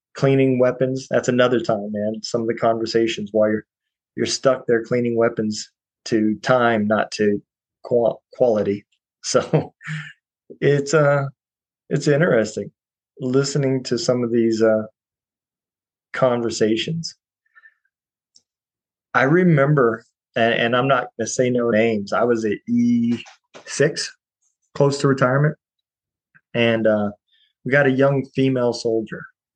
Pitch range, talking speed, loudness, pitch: 115-135 Hz, 120 wpm, -20 LUFS, 120 Hz